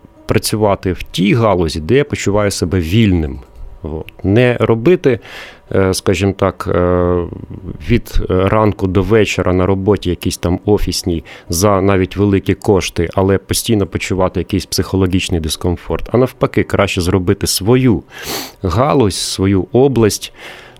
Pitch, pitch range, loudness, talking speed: 95 Hz, 90-105 Hz, -14 LUFS, 120 wpm